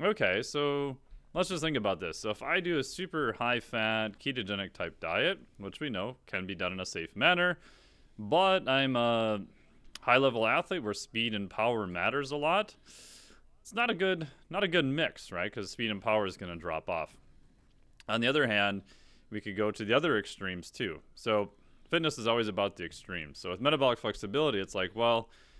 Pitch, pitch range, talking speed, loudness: 115 Hz, 100-145 Hz, 195 wpm, -31 LUFS